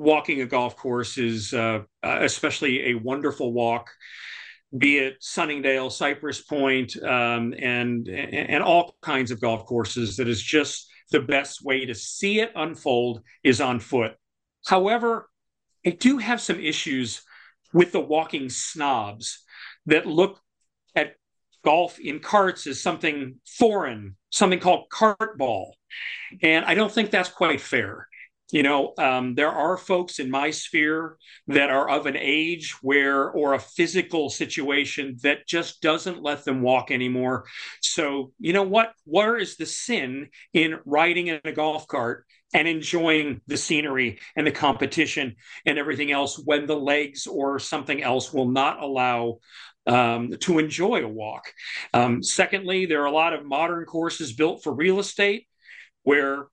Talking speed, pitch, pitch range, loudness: 150 wpm, 145 Hz, 130-165 Hz, -23 LUFS